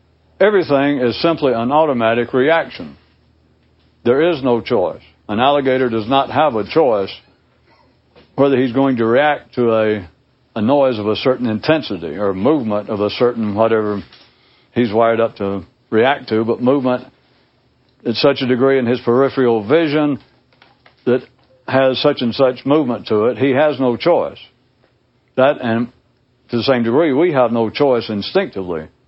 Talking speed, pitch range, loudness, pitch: 155 wpm, 115-135 Hz, -16 LUFS, 125 Hz